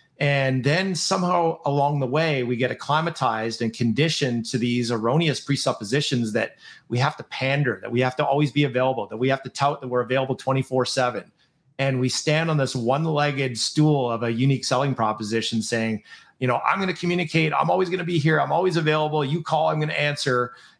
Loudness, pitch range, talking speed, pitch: -23 LUFS, 125-155 Hz, 205 wpm, 135 Hz